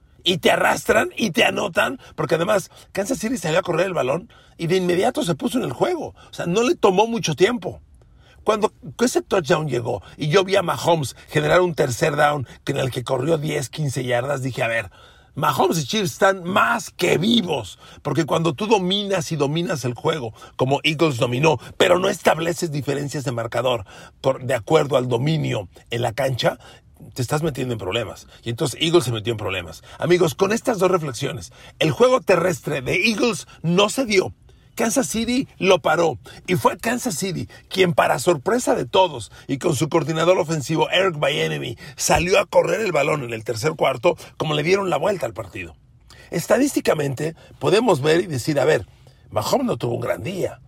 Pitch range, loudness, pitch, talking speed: 130-190 Hz, -21 LUFS, 160 Hz, 190 wpm